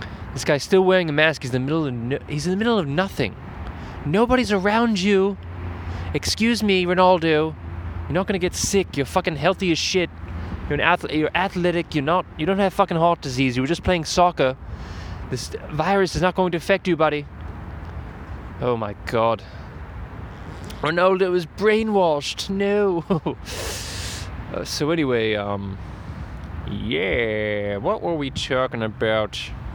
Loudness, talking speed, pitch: -22 LUFS, 150 wpm, 145 Hz